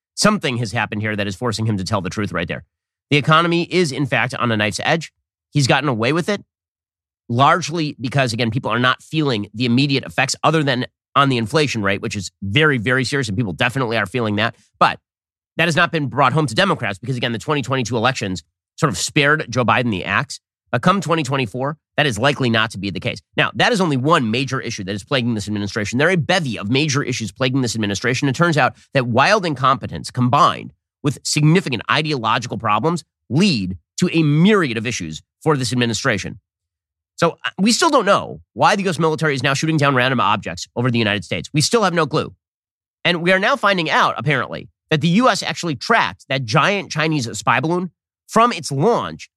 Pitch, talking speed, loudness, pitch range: 130 Hz, 210 wpm, -18 LUFS, 110-155 Hz